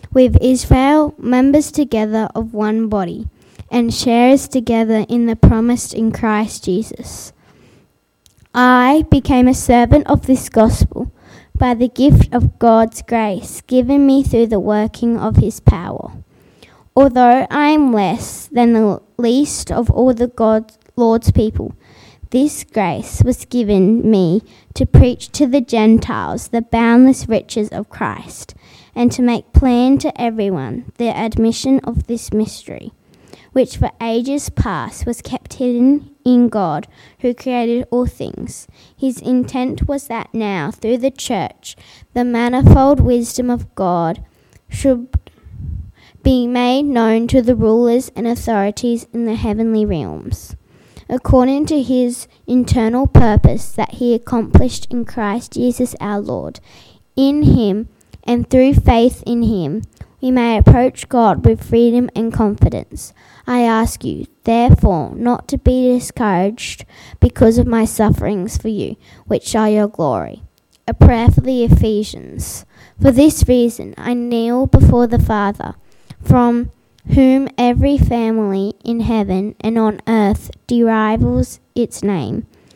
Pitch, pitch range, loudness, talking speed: 235 Hz, 220-250 Hz, -14 LUFS, 135 wpm